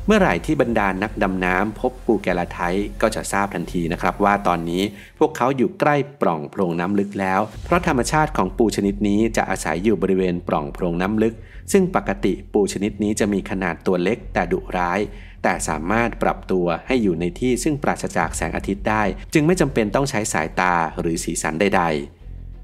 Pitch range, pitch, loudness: 90-115 Hz, 100 Hz, -21 LUFS